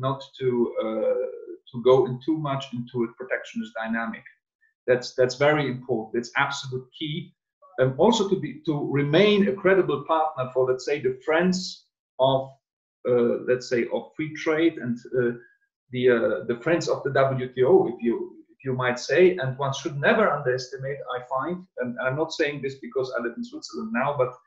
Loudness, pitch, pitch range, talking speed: -25 LUFS, 140 Hz, 125-185 Hz, 185 wpm